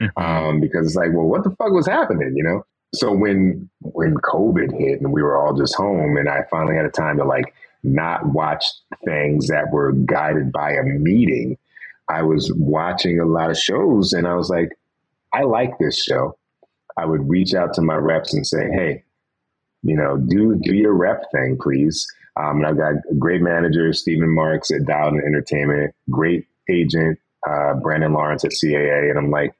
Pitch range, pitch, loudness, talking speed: 75-85 Hz, 80 Hz, -19 LUFS, 195 wpm